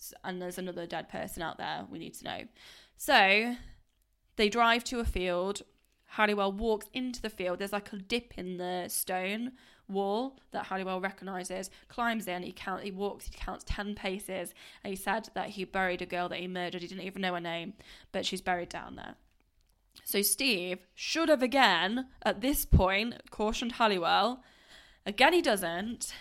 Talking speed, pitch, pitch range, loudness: 180 wpm, 195 Hz, 185-225 Hz, -31 LUFS